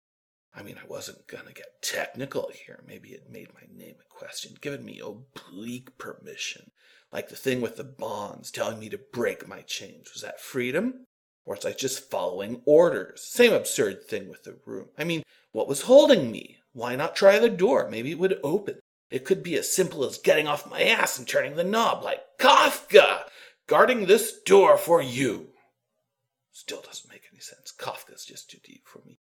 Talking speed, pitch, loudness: 195 wpm, 255 Hz, -23 LUFS